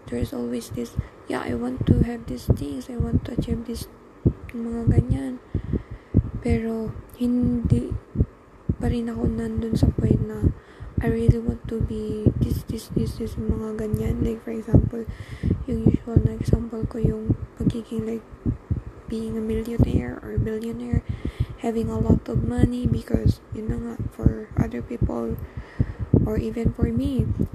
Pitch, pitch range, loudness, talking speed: 115 Hz, 110-120 Hz, -25 LUFS, 150 wpm